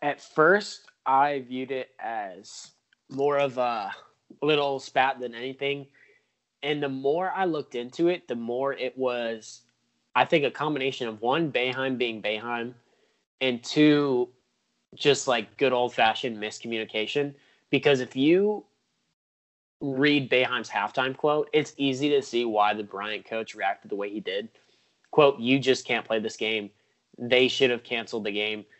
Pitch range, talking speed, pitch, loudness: 115-140 Hz, 150 wpm, 130 Hz, -26 LUFS